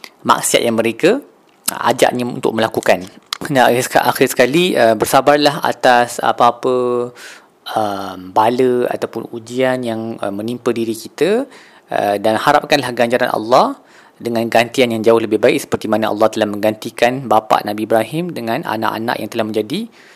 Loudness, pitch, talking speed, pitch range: -15 LUFS, 115 Hz, 130 wpm, 110-125 Hz